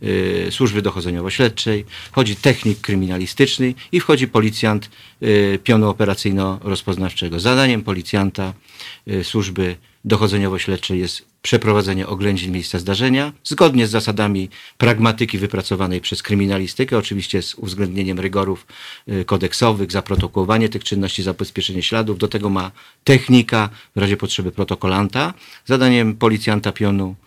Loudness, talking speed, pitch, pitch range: -18 LUFS, 105 wpm, 100 Hz, 95-115 Hz